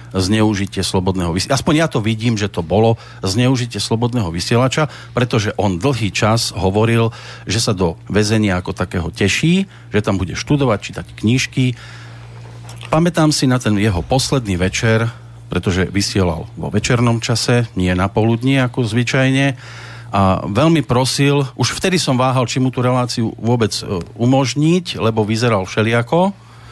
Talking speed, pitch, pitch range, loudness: 145 wpm, 115 Hz, 105-130 Hz, -16 LUFS